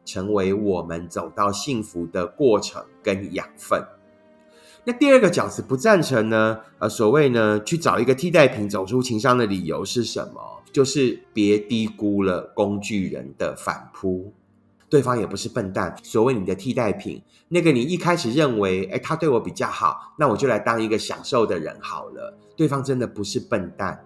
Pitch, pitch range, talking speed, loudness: 110 Hz, 100-135 Hz, 270 characters per minute, -22 LUFS